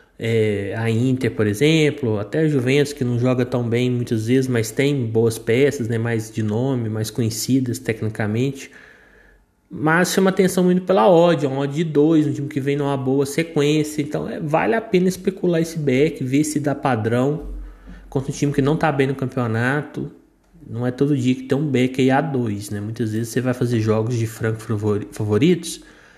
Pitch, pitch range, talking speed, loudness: 130 Hz, 115-150 Hz, 195 wpm, -20 LUFS